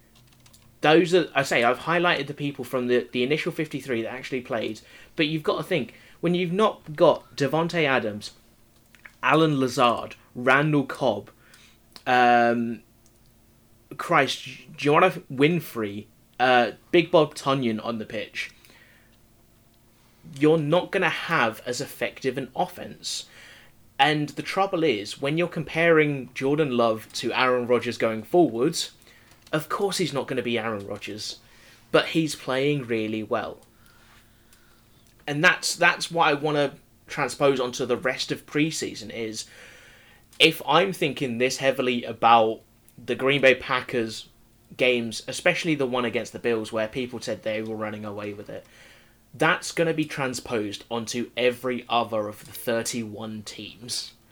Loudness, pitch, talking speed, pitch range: -24 LUFS, 125 Hz, 145 wpm, 115-150 Hz